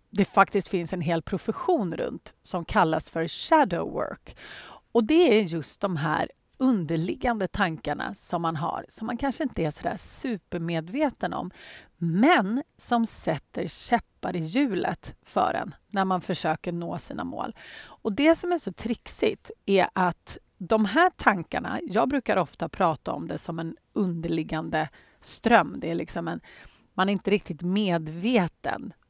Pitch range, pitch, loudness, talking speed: 170-240 Hz, 195 Hz, -27 LUFS, 155 wpm